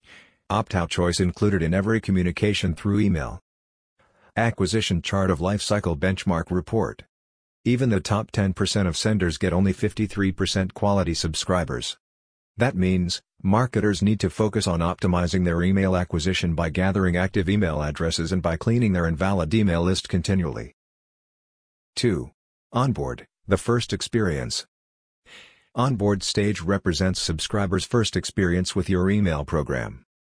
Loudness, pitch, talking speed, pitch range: -23 LUFS, 95 Hz, 130 wpm, 85-105 Hz